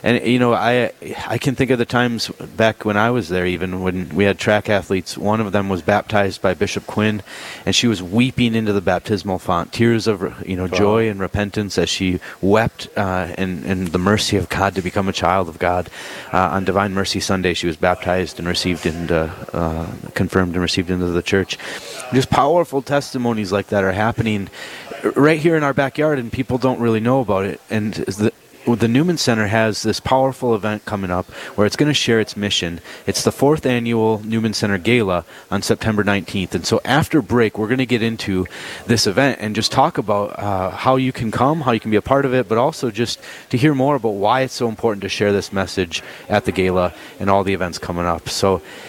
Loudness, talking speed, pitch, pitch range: -18 LUFS, 220 wpm, 105 Hz, 95-120 Hz